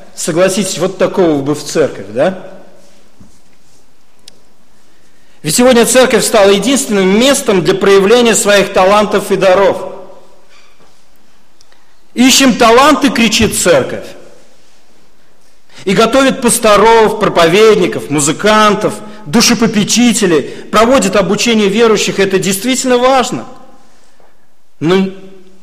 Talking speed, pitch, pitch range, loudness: 85 wpm, 210 Hz, 190-235 Hz, -9 LUFS